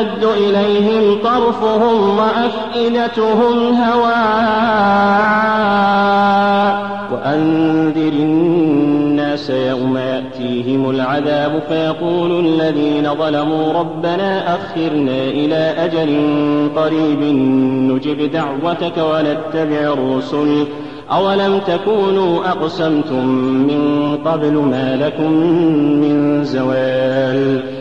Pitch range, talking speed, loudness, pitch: 145-200 Hz, 65 wpm, -15 LUFS, 155 Hz